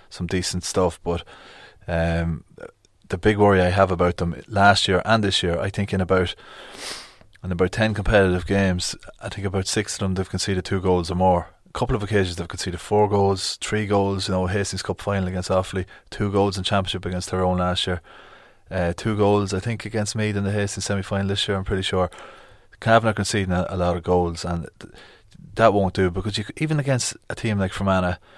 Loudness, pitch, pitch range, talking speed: -22 LUFS, 95 Hz, 90-100 Hz, 210 wpm